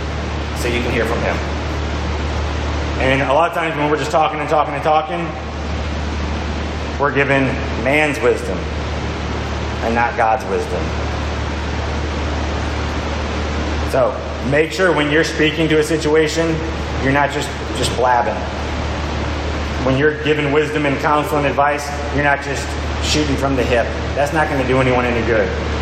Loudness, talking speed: -18 LUFS, 150 wpm